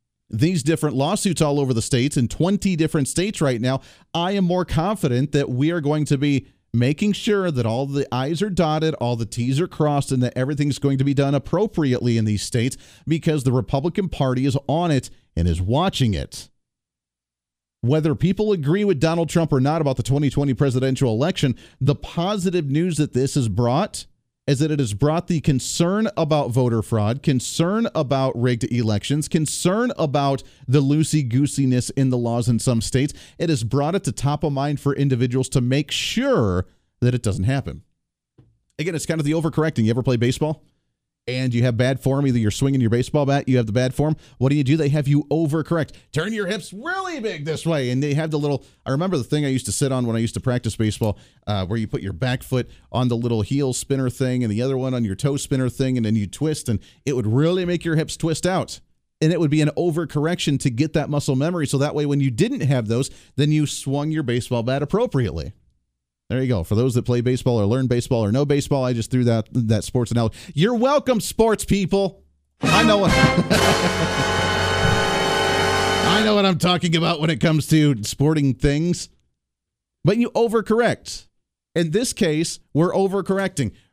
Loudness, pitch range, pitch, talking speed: -21 LUFS, 125-160 Hz, 140 Hz, 205 wpm